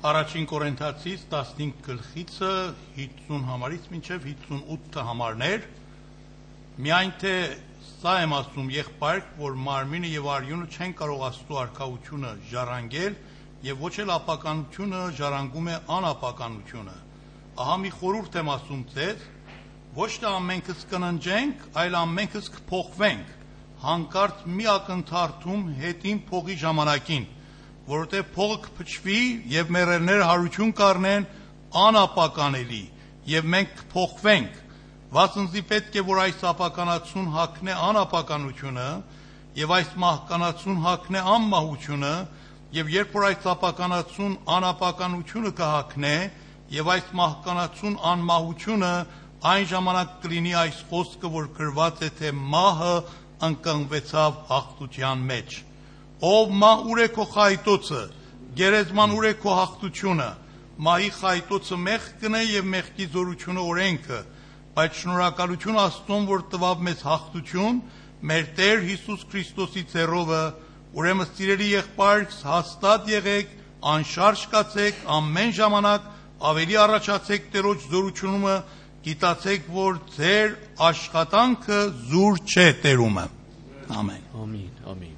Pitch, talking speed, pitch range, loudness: 175 Hz, 105 wpm, 150-195 Hz, -24 LUFS